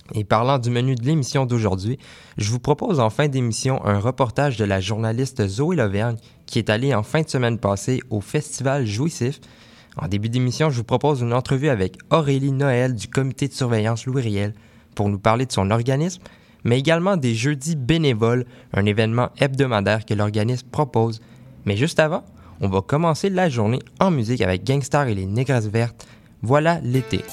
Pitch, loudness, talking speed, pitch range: 125 Hz, -21 LUFS, 180 wpm, 110-140 Hz